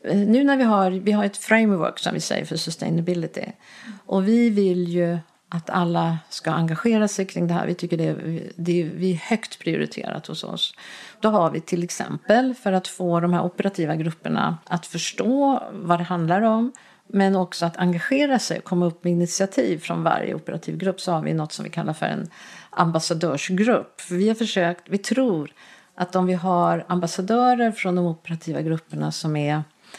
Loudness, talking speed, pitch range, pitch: -23 LUFS, 190 wpm, 170-210 Hz, 180 Hz